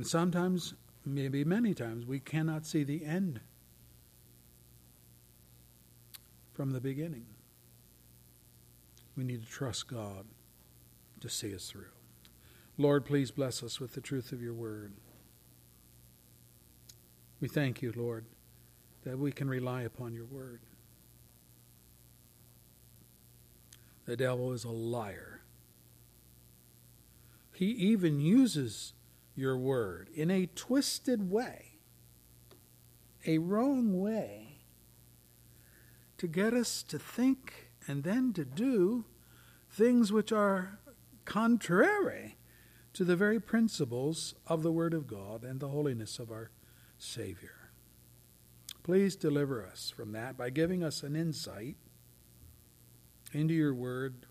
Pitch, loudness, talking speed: 120 Hz, -34 LUFS, 110 wpm